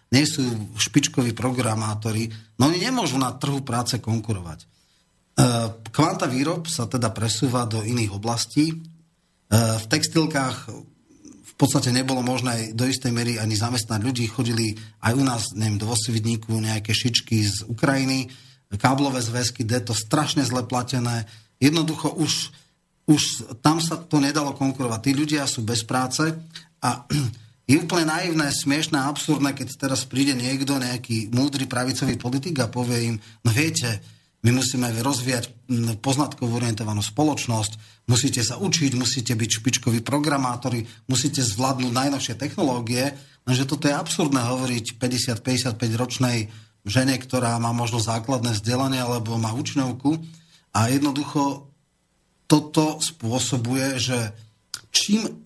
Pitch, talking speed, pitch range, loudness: 125 Hz, 130 wpm, 115-140 Hz, -23 LUFS